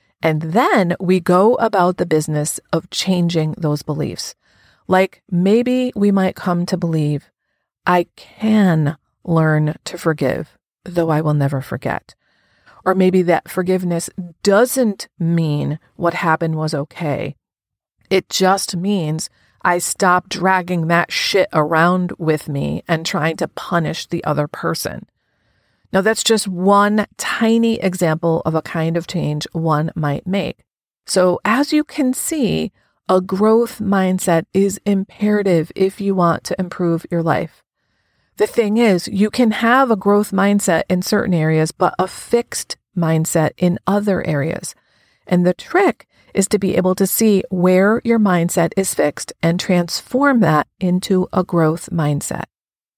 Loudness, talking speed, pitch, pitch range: -17 LUFS, 145 wpm, 180 Hz, 160-200 Hz